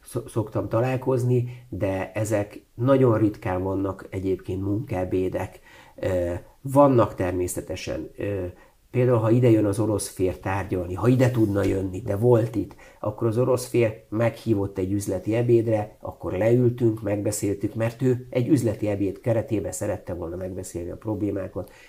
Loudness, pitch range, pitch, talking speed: -24 LUFS, 95-115 Hz, 105 Hz, 130 wpm